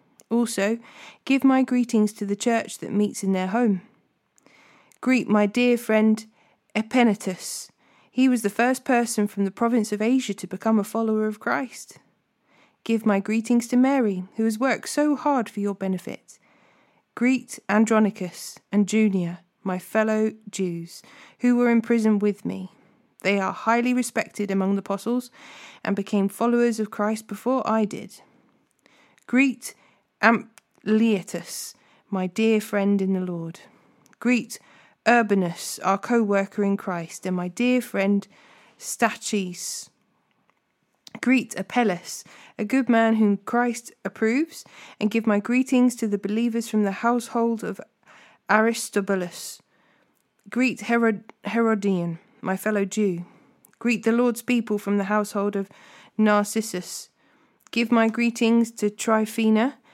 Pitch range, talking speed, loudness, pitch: 200-235 Hz, 135 wpm, -23 LUFS, 220 Hz